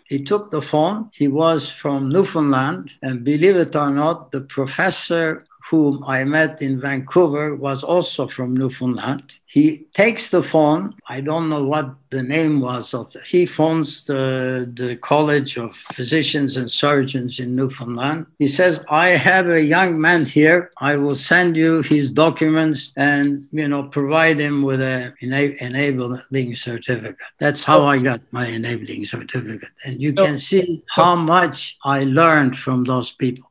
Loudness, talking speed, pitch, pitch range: -18 LUFS, 160 wpm, 145 Hz, 130-160 Hz